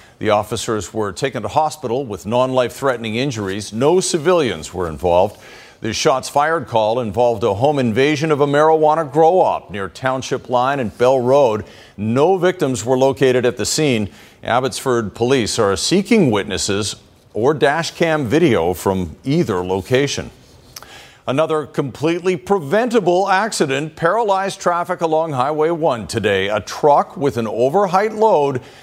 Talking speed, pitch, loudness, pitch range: 145 wpm, 135 Hz, -17 LUFS, 110-160 Hz